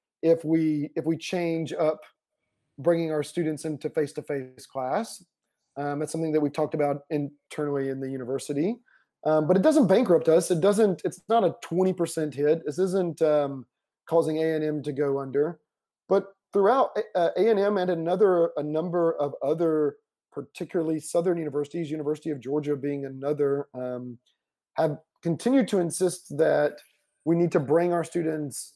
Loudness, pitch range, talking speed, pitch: -26 LUFS, 145-175 Hz, 155 wpm, 160 Hz